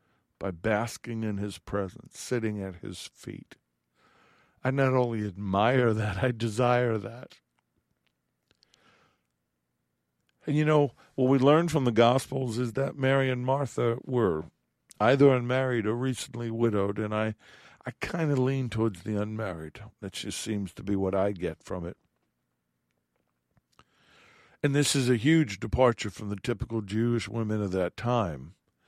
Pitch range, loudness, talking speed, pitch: 95-130 Hz, -28 LUFS, 145 wpm, 110 Hz